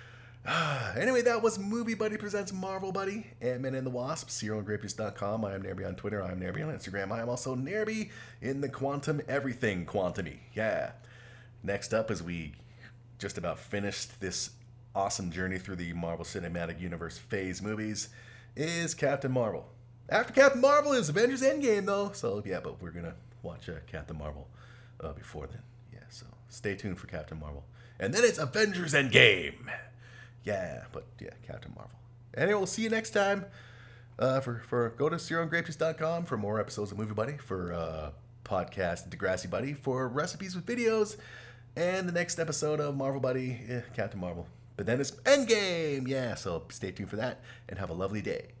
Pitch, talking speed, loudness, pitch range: 120 Hz, 180 wpm, -31 LUFS, 105-155 Hz